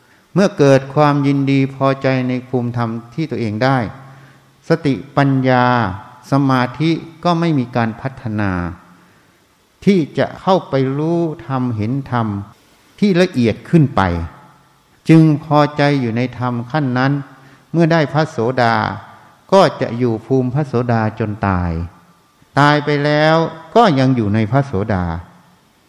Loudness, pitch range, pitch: -16 LUFS, 115-150 Hz, 130 Hz